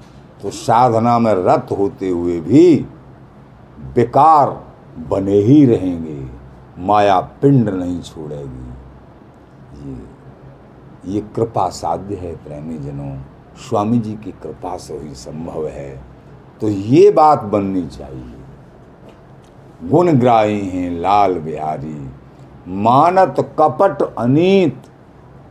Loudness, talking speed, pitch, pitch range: -15 LUFS, 100 wpm, 100 Hz, 75-120 Hz